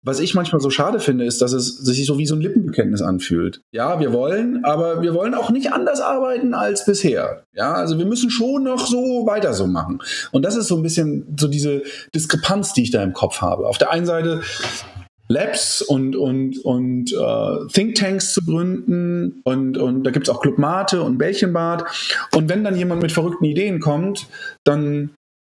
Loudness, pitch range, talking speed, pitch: -19 LUFS, 135-200 Hz, 200 wpm, 165 Hz